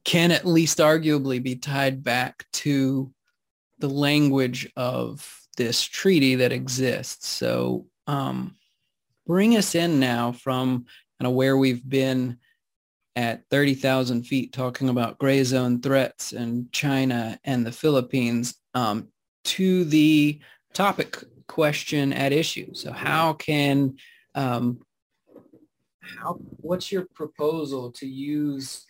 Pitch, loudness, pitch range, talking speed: 135 Hz, -24 LUFS, 125-150 Hz, 120 wpm